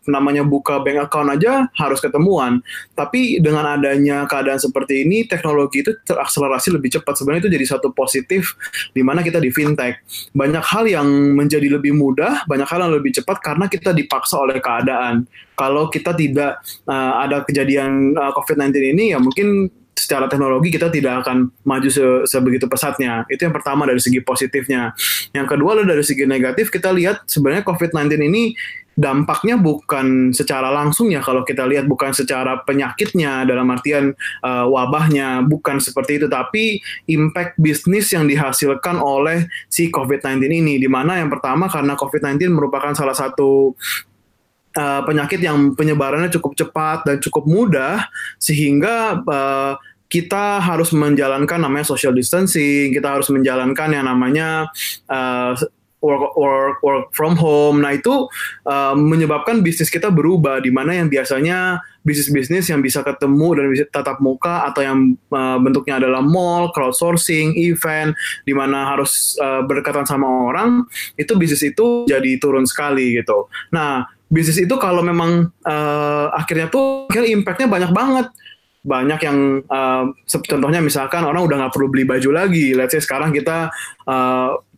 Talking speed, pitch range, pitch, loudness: 150 wpm, 135-170 Hz, 145 Hz, -16 LUFS